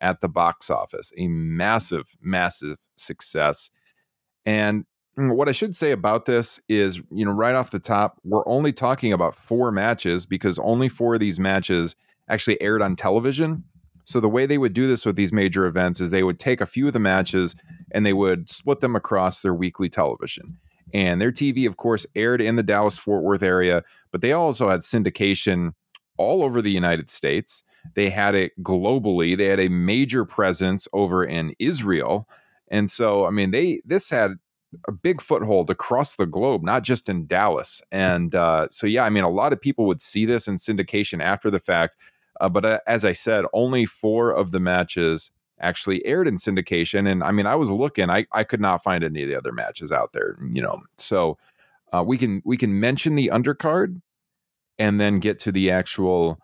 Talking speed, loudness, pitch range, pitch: 200 wpm, -22 LUFS, 90-120 Hz, 100 Hz